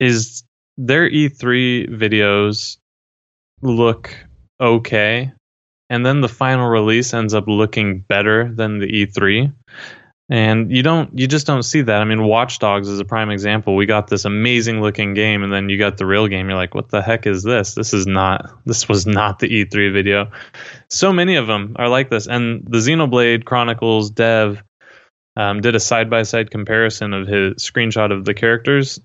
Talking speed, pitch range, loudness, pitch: 180 wpm, 100-120 Hz, -16 LUFS, 110 Hz